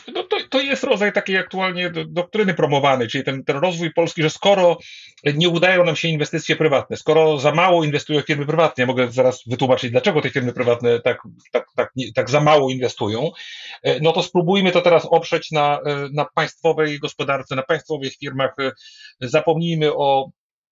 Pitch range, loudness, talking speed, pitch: 140-175 Hz, -19 LUFS, 170 wpm, 155 Hz